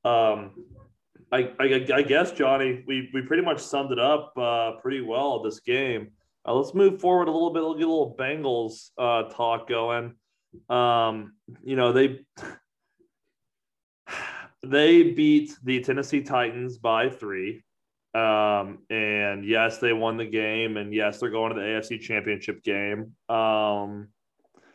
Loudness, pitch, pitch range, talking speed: -25 LUFS, 120 Hz, 110-135 Hz, 145 wpm